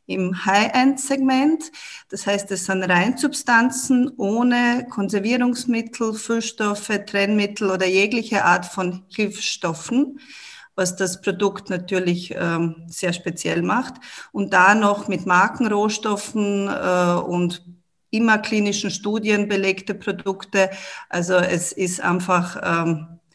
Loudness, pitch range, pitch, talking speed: -20 LUFS, 180-225 Hz, 200 Hz, 105 wpm